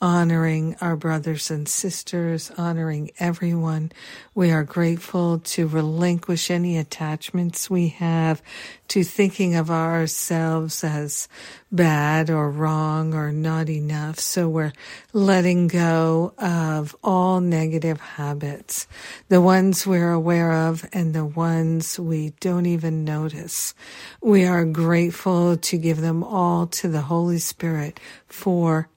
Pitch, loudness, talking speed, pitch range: 165 Hz, -22 LUFS, 120 wpm, 160-175 Hz